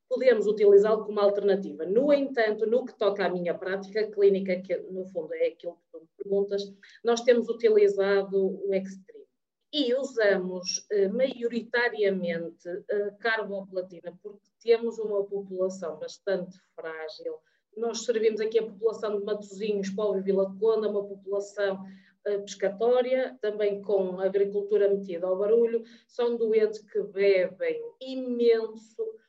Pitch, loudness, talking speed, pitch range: 205 Hz, -27 LUFS, 135 wpm, 195-230 Hz